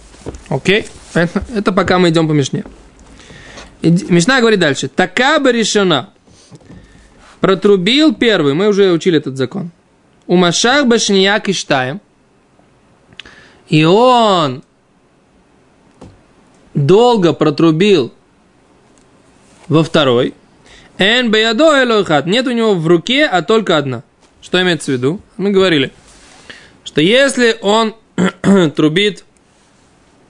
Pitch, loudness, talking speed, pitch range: 190 Hz, -12 LUFS, 105 wpm, 165-220 Hz